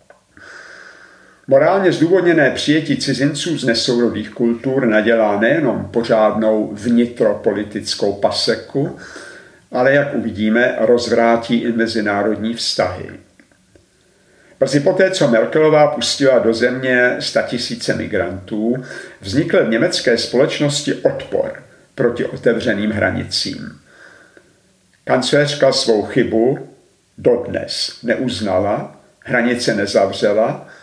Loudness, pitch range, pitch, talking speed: -16 LUFS, 115-145 Hz, 120 Hz, 85 wpm